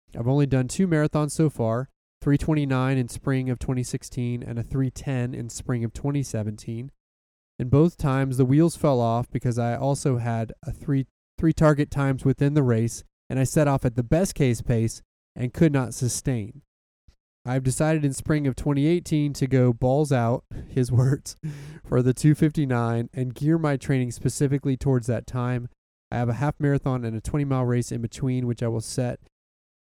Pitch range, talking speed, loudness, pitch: 120-145 Hz, 200 wpm, -24 LUFS, 130 Hz